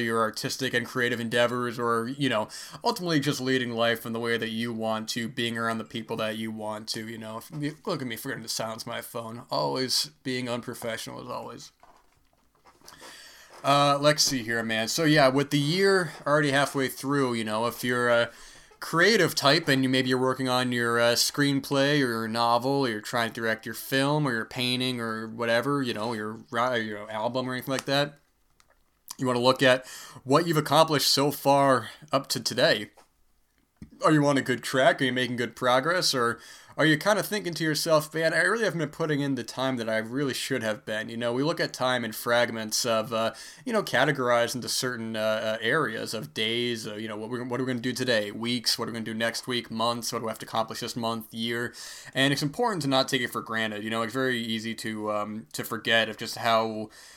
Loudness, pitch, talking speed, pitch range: -26 LUFS, 120 Hz, 225 wpm, 115-135 Hz